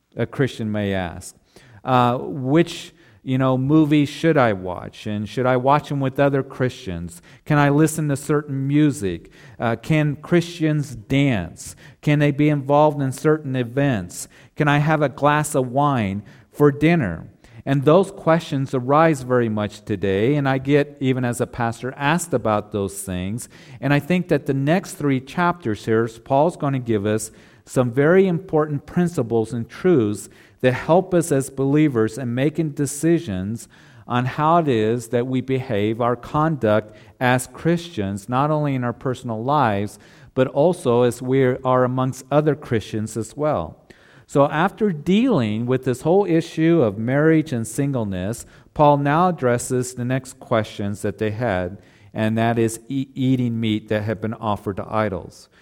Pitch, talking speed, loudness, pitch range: 130 Hz, 160 wpm, -20 LUFS, 115-150 Hz